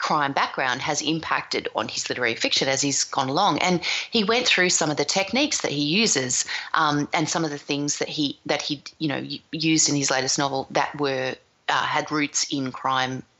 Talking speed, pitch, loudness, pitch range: 210 wpm, 145 Hz, -23 LUFS, 135-160 Hz